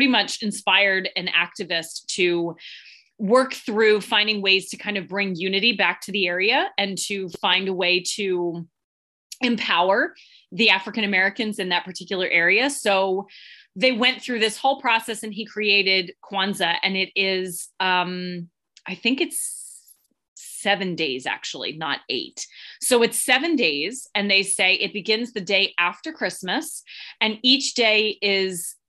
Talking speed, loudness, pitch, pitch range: 150 wpm, -21 LUFS, 200 Hz, 185-230 Hz